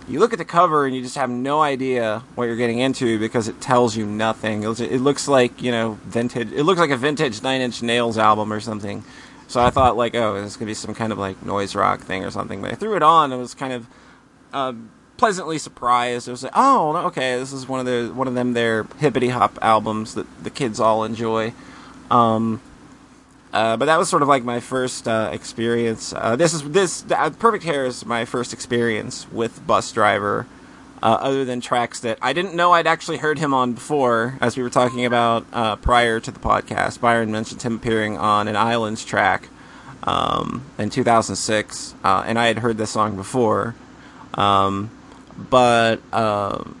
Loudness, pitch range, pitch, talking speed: -20 LUFS, 110-130 Hz, 120 Hz, 215 wpm